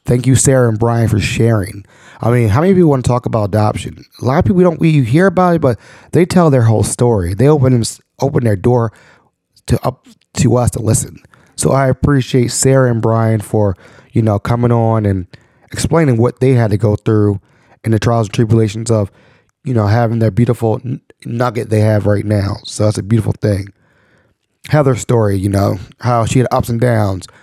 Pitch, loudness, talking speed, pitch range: 120 Hz, -13 LUFS, 210 wpm, 110-130 Hz